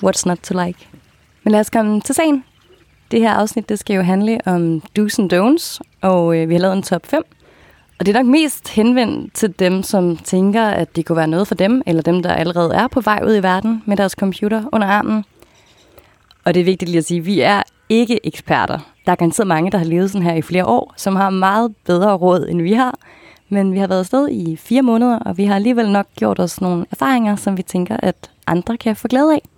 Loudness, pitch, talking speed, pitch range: -16 LUFS, 200 Hz, 240 wpm, 180-225 Hz